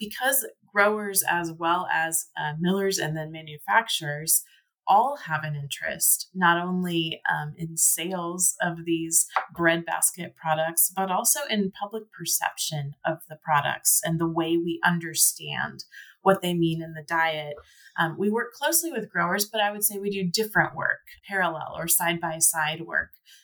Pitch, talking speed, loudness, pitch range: 170 Hz, 160 wpm, -24 LUFS, 160-195 Hz